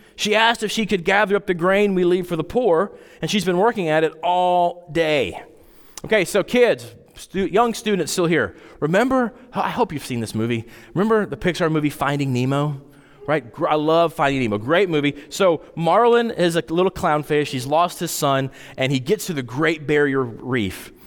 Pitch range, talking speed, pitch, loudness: 140-195 Hz, 195 wpm, 165 Hz, -20 LUFS